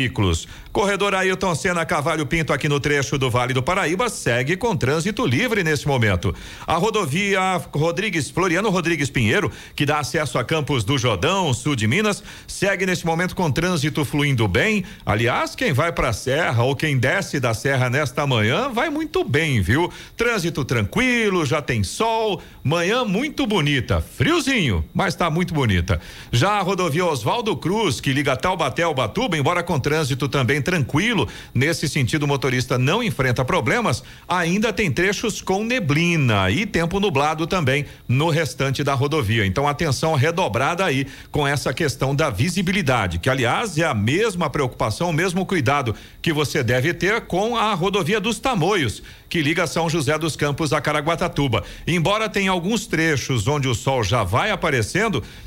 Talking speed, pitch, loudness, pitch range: 165 wpm, 155 Hz, -20 LUFS, 130-185 Hz